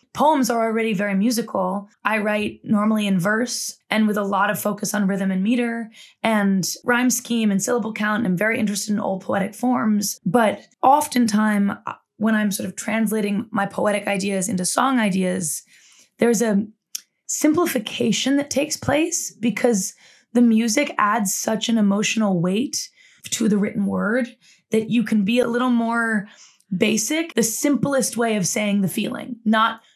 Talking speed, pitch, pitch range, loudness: 160 wpm, 220 Hz, 205-240 Hz, -21 LUFS